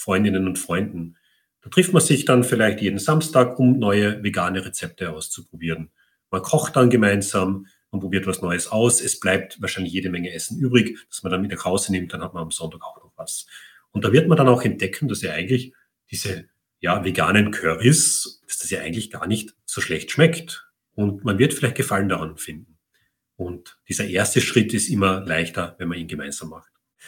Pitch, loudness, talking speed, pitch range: 100 Hz, -21 LUFS, 195 wpm, 90-125 Hz